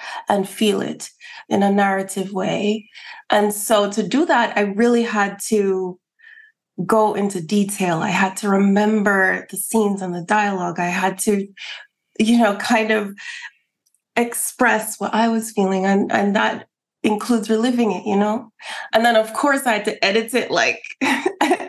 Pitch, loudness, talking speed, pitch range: 210 Hz, -19 LUFS, 160 wpm, 200-230 Hz